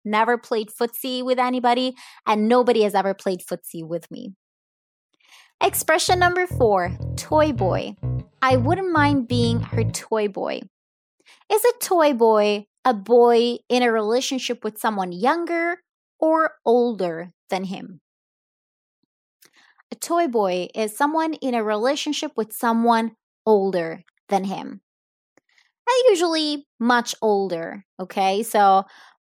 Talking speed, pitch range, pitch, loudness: 125 wpm, 200-285 Hz, 235 Hz, -21 LUFS